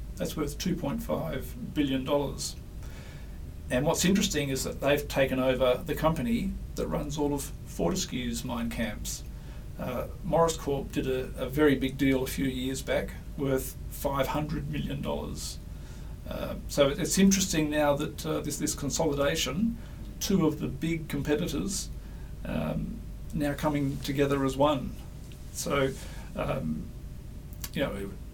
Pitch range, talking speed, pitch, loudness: 120-150 Hz, 135 wpm, 140 Hz, -30 LUFS